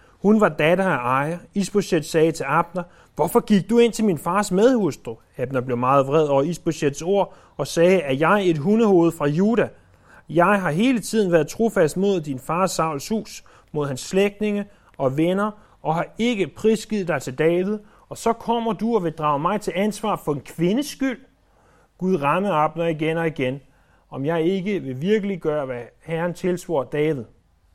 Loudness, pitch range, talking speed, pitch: -21 LUFS, 150-205 Hz, 185 wpm, 175 Hz